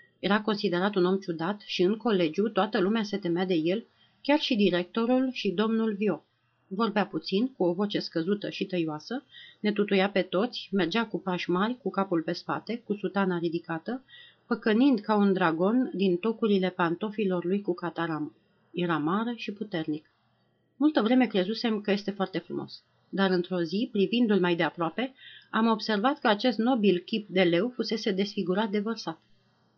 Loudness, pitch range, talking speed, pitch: -28 LUFS, 175-225 Hz, 165 wpm, 195 Hz